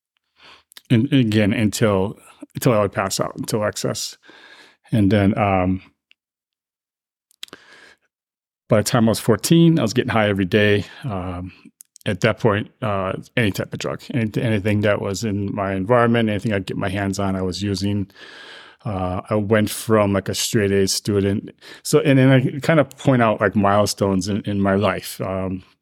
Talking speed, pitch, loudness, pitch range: 170 wpm, 105 Hz, -20 LUFS, 100-115 Hz